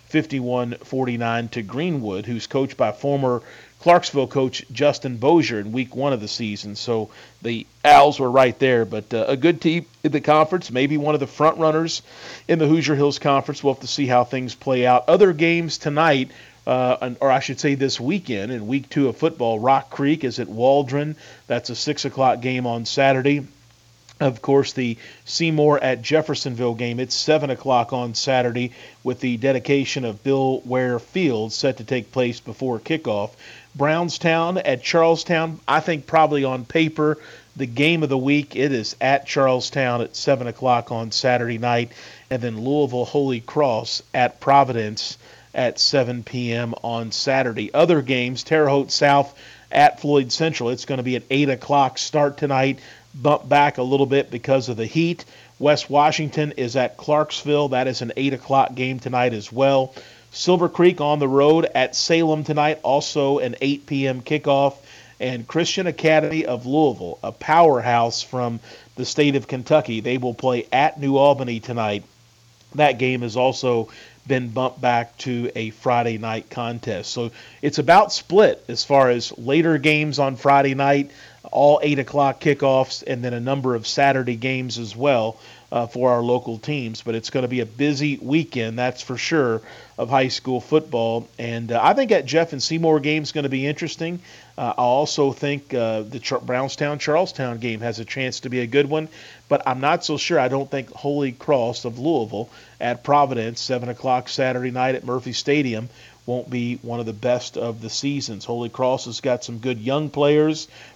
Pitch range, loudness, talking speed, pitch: 120-145 Hz, -20 LUFS, 180 wpm, 130 Hz